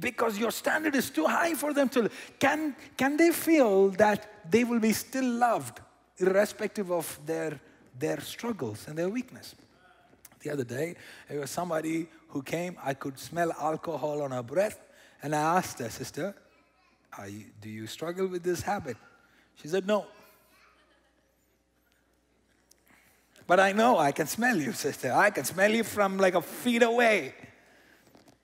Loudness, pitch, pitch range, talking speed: -28 LUFS, 175 Hz, 140-215 Hz, 160 wpm